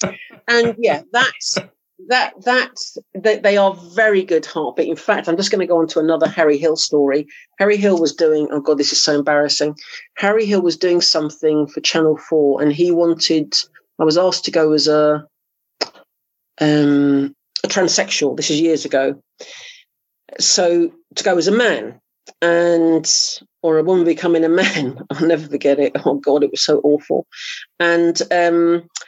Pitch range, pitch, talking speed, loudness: 150-185 Hz, 165 Hz, 175 wpm, -16 LUFS